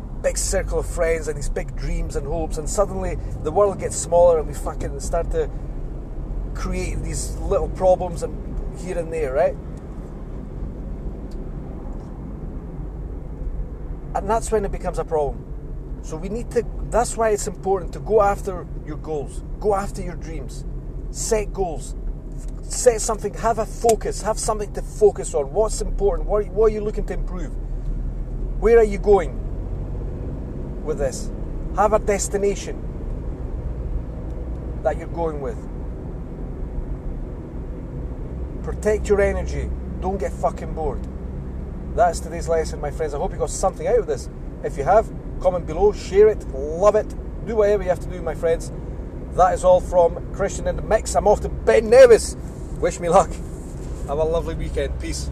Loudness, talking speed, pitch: -22 LUFS, 155 wpm, 165 Hz